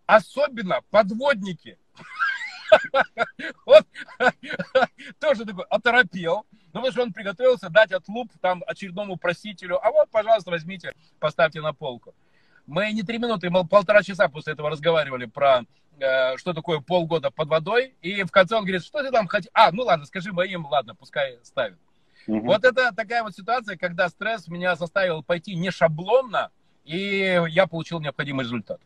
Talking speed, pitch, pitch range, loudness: 150 wpm, 190 Hz, 170-235 Hz, -23 LUFS